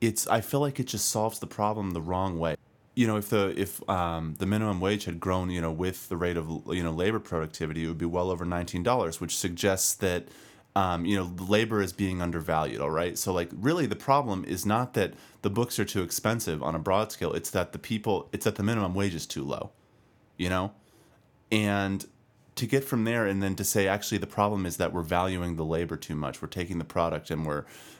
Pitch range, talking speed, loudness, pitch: 85-110 Hz, 235 wpm, -29 LUFS, 95 Hz